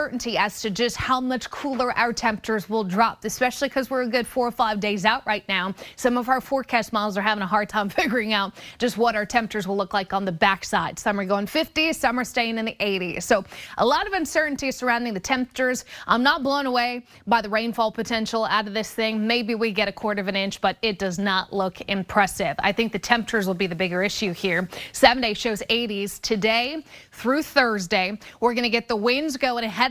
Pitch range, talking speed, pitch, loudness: 205-245 Hz, 225 wpm, 225 Hz, -23 LUFS